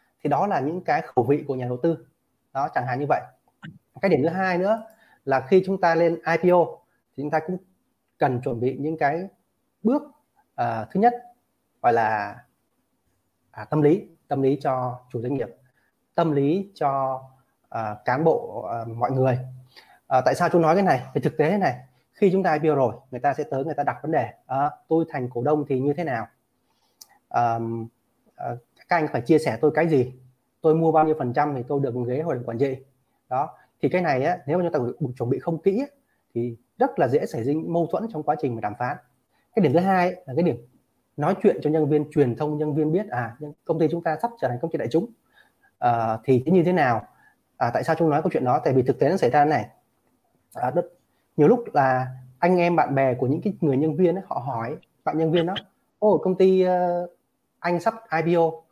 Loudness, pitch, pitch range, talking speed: -23 LUFS, 150 Hz, 130-175 Hz, 230 wpm